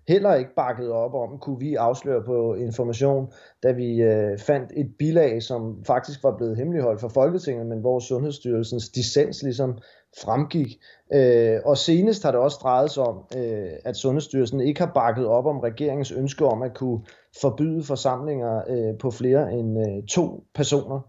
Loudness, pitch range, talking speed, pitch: -23 LUFS, 115-145 Hz, 155 wpm, 130 Hz